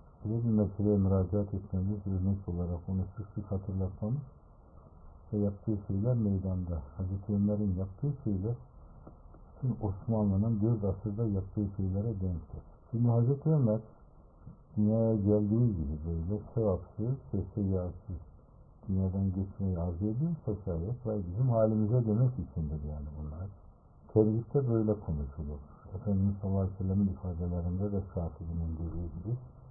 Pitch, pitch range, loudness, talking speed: 100 Hz, 90-110 Hz, -33 LUFS, 120 wpm